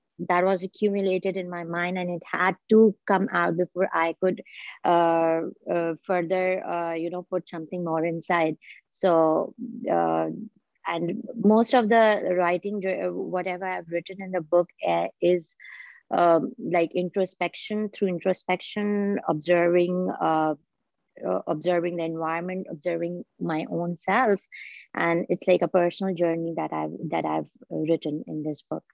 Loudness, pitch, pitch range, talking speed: -25 LUFS, 175 Hz, 165-190 Hz, 145 wpm